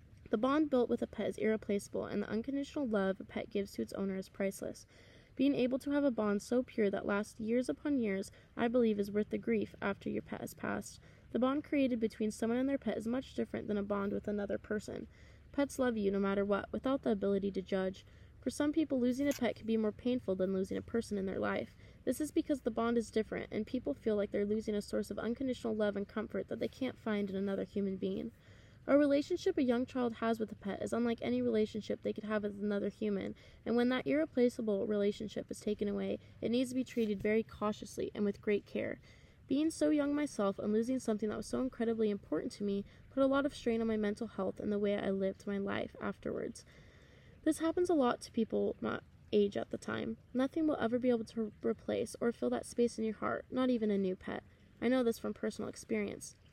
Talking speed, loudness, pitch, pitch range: 235 wpm, -36 LUFS, 225 Hz, 205-255 Hz